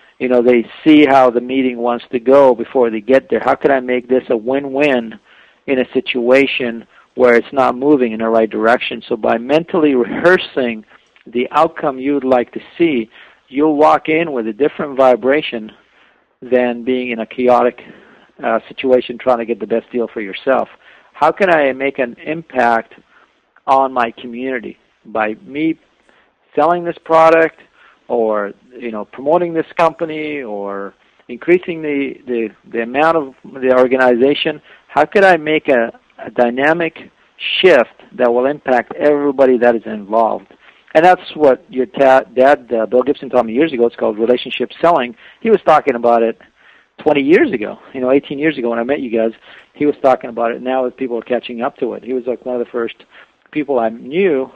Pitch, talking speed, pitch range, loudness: 130 Hz, 185 wpm, 120-145 Hz, -15 LUFS